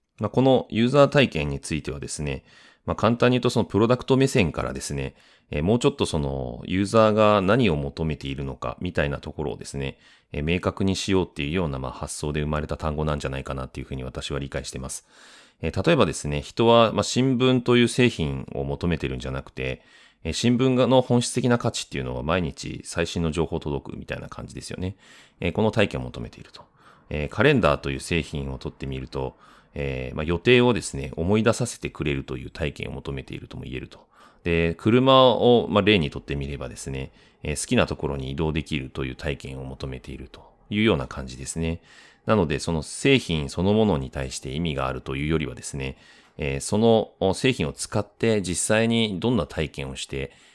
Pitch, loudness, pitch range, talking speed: 80 Hz, -24 LUFS, 70-110 Hz, 405 characters per minute